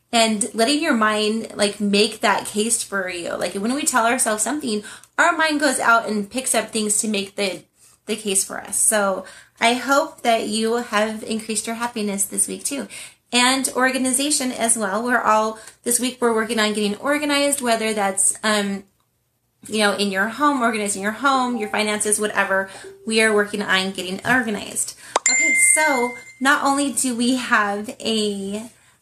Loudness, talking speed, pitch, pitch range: -19 LUFS, 175 wpm, 220 Hz, 205-250 Hz